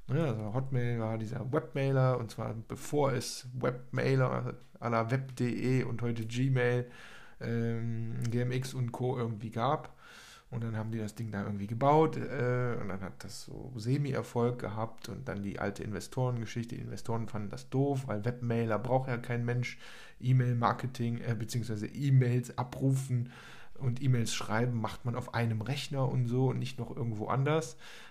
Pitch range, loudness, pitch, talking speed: 115-130 Hz, -33 LUFS, 120 Hz, 160 wpm